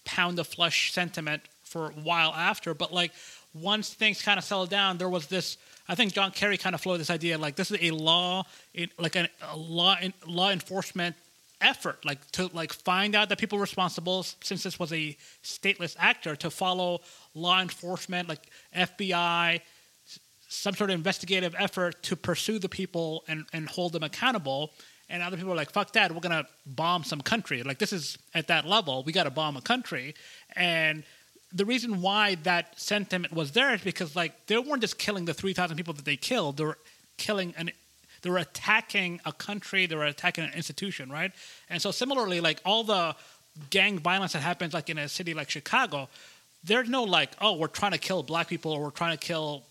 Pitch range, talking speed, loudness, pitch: 160-195 Hz, 195 wpm, -28 LUFS, 175 Hz